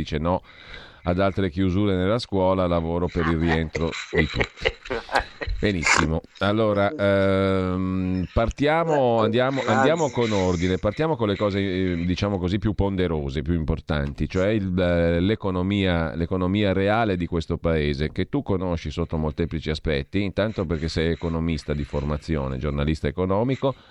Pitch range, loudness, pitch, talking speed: 80-100 Hz, -23 LUFS, 90 Hz, 135 wpm